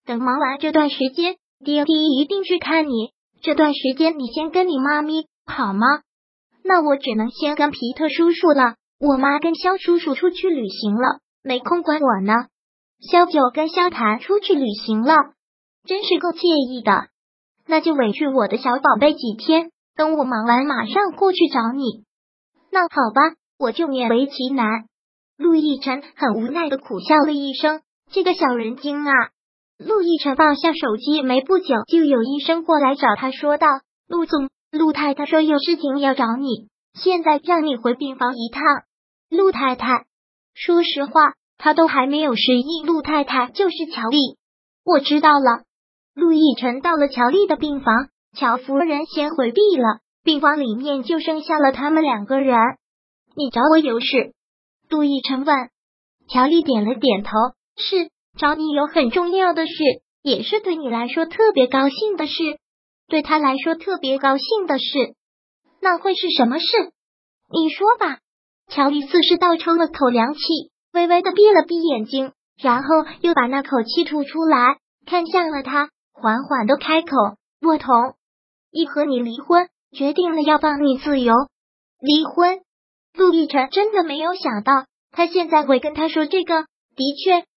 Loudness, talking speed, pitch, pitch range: -18 LUFS, 235 characters per minute, 295 Hz, 260-330 Hz